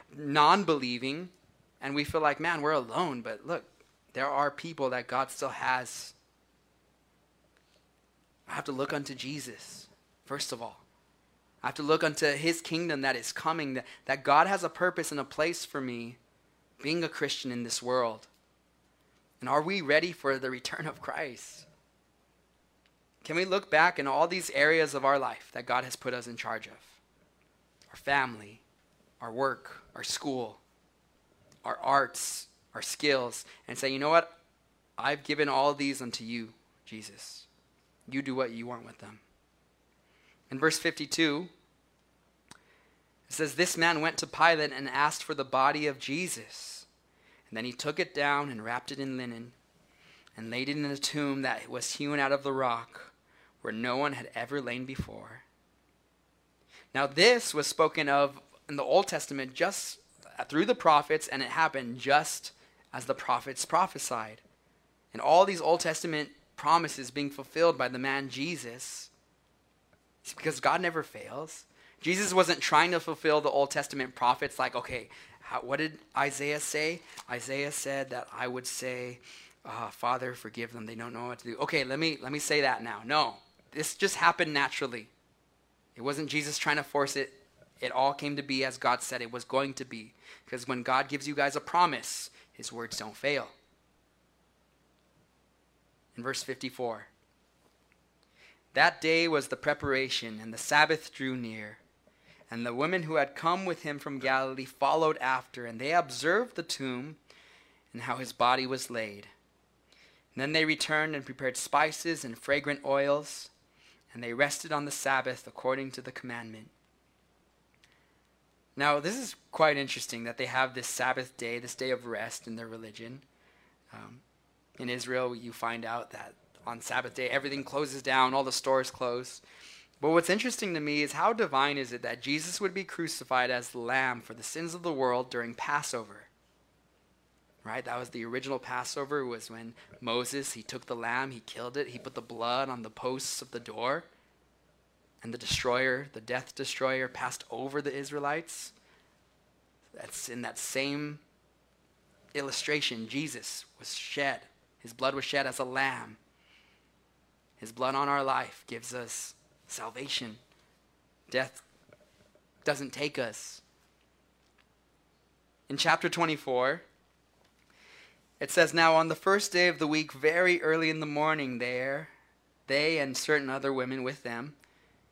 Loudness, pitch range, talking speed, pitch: -31 LUFS, 125-150 Hz, 165 wpm, 135 Hz